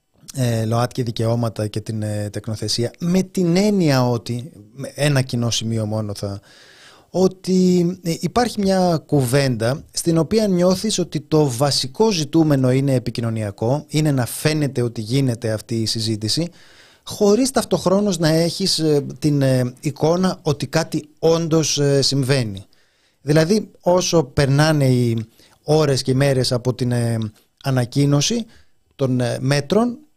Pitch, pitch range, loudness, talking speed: 140 Hz, 120-170 Hz, -19 LUFS, 115 wpm